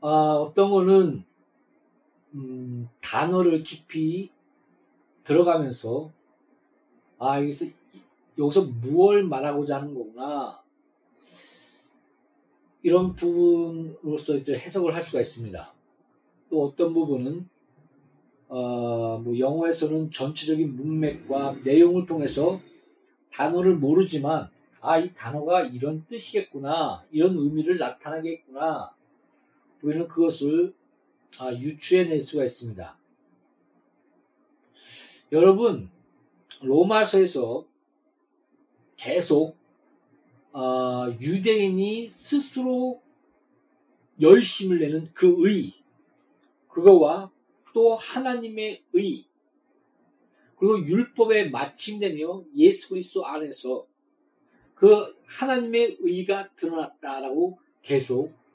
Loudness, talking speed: -24 LUFS, 195 characters per minute